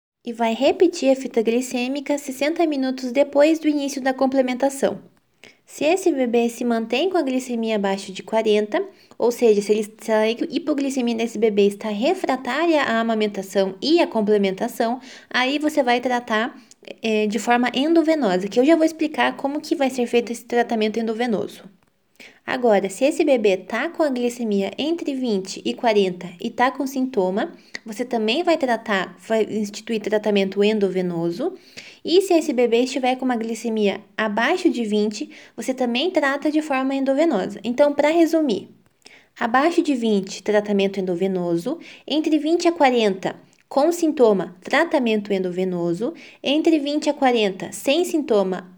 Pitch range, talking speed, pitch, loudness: 215-290 Hz, 150 wpm, 245 Hz, -21 LUFS